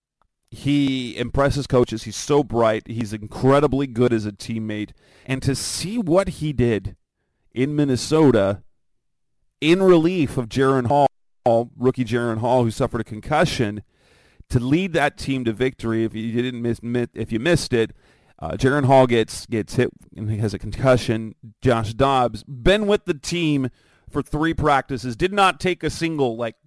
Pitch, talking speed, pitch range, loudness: 125 Hz, 160 wpm, 115-145 Hz, -21 LUFS